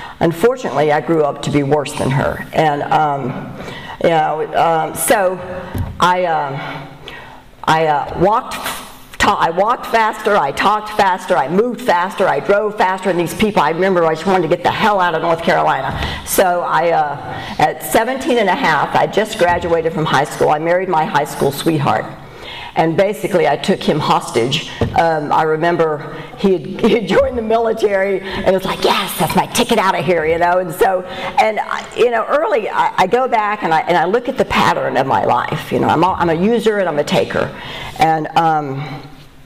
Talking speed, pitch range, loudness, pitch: 200 wpm, 160-210 Hz, -15 LUFS, 185 Hz